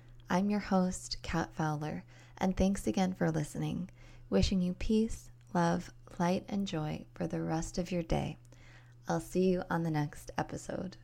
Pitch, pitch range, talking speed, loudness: 165 Hz, 125-185 Hz, 165 wpm, -34 LUFS